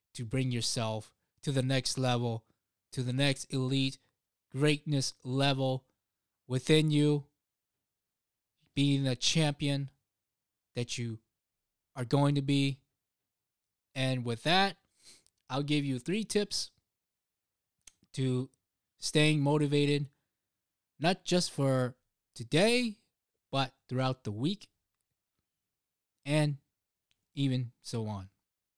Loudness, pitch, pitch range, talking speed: -31 LUFS, 130 Hz, 110-145 Hz, 100 wpm